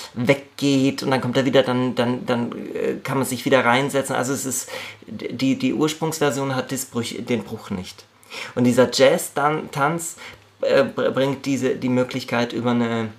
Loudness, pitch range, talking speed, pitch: -21 LUFS, 125-140 Hz, 165 wpm, 130 Hz